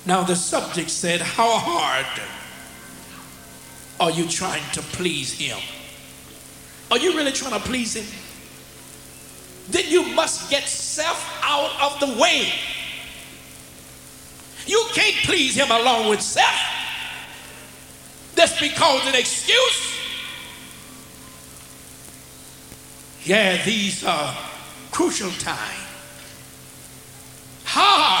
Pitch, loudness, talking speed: 165 Hz, -20 LUFS, 95 wpm